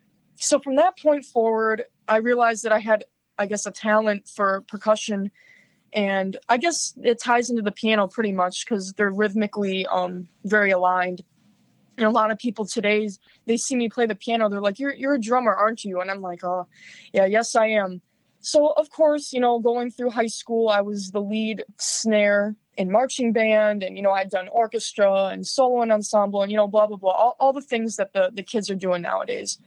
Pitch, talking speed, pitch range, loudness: 215 Hz, 210 wpm, 195-235 Hz, -22 LUFS